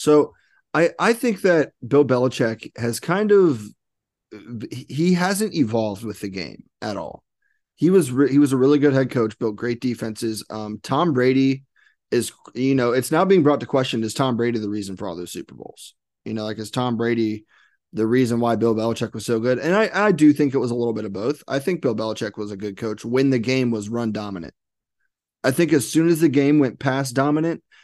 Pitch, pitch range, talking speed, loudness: 125 Hz, 110-145 Hz, 220 wpm, -21 LUFS